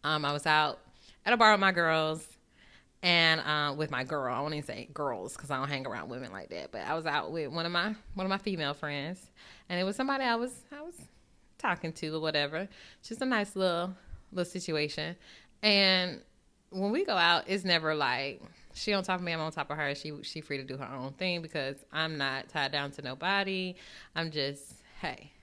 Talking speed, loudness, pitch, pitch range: 220 wpm, -31 LUFS, 160 Hz, 150-190 Hz